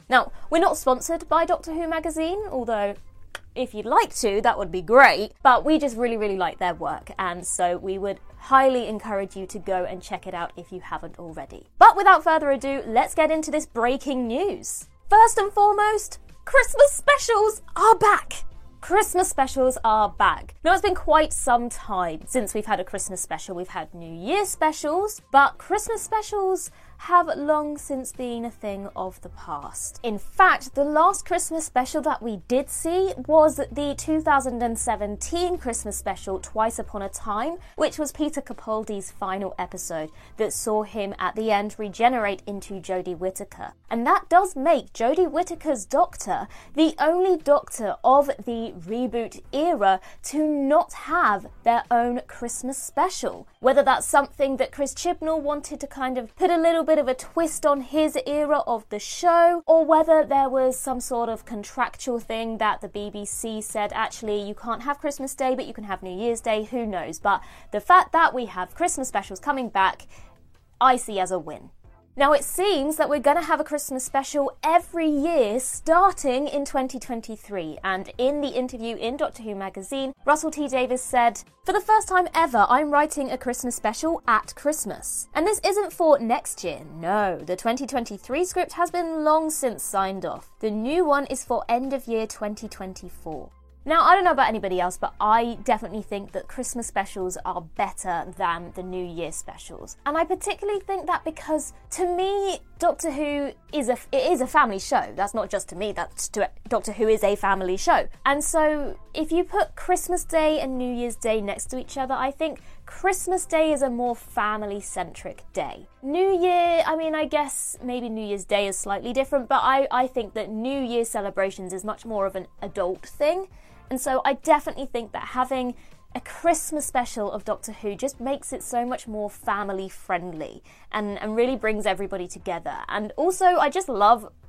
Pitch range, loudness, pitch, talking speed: 210-315 Hz, -23 LUFS, 255 Hz, 185 wpm